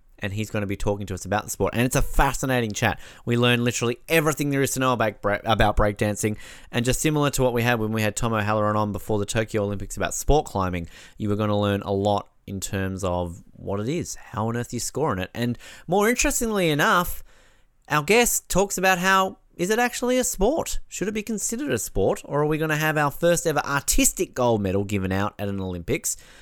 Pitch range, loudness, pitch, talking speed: 100-155 Hz, -24 LUFS, 120 Hz, 240 wpm